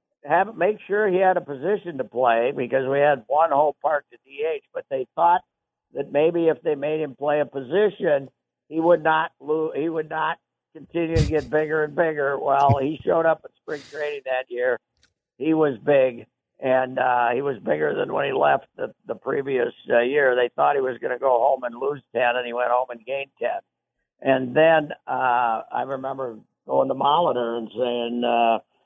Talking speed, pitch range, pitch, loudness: 200 wpm, 130-165 Hz, 145 Hz, -22 LUFS